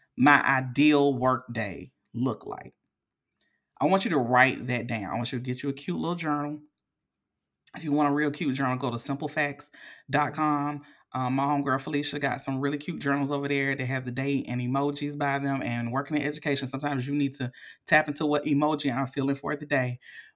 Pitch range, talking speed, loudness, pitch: 130-145 Hz, 205 wpm, -27 LUFS, 140 Hz